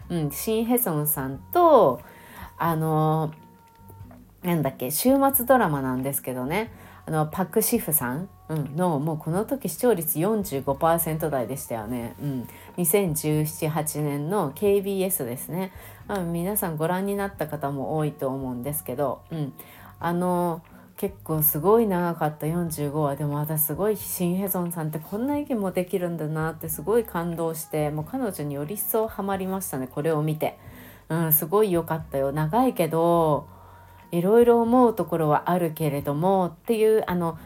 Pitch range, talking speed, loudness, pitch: 145-190 Hz, 315 characters per minute, -25 LUFS, 160 Hz